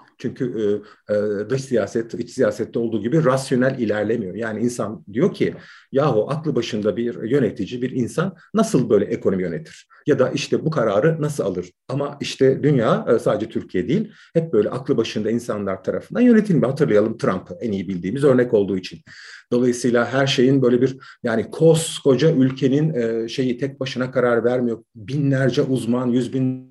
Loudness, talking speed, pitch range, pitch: -20 LUFS, 165 wpm, 115-140 Hz, 125 Hz